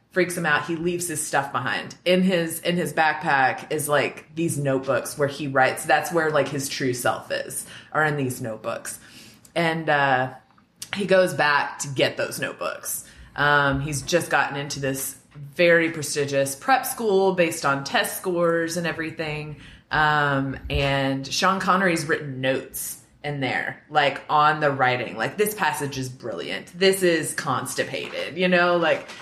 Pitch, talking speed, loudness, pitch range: 150 Hz, 160 wpm, -23 LUFS, 140-170 Hz